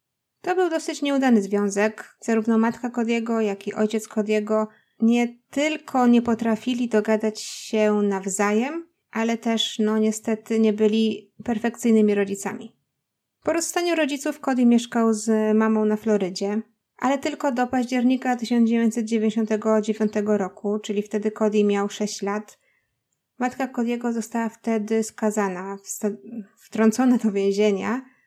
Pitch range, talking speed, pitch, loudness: 215-240 Hz, 120 wpm, 220 Hz, -23 LUFS